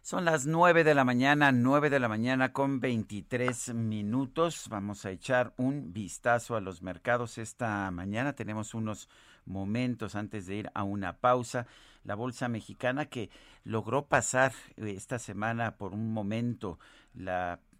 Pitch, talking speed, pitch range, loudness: 115 Hz, 150 wpm, 105-130 Hz, -31 LUFS